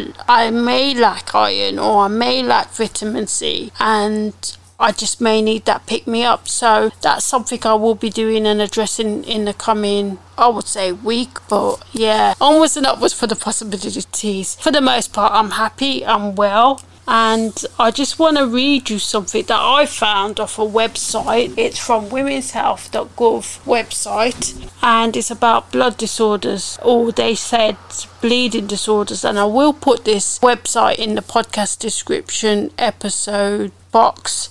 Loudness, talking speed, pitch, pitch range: -16 LUFS, 160 wpm, 225 Hz, 210-240 Hz